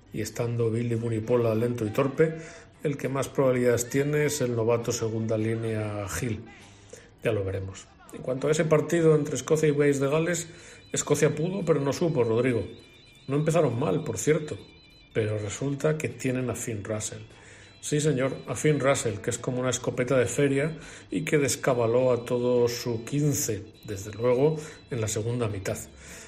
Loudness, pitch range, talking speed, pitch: -27 LUFS, 110-145 Hz, 170 wpm, 125 Hz